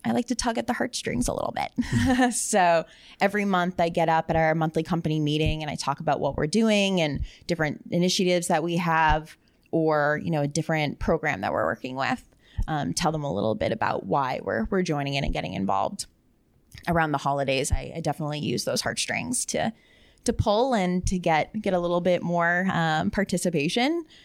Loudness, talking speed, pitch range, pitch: -25 LUFS, 200 wpm, 155-190 Hz, 170 Hz